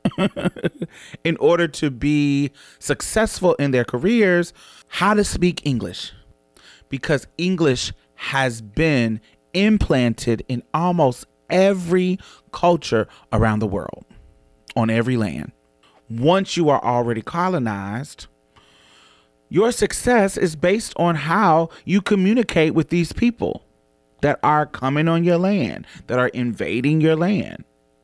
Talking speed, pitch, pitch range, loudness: 115 wpm, 150 Hz, 115-180 Hz, -20 LUFS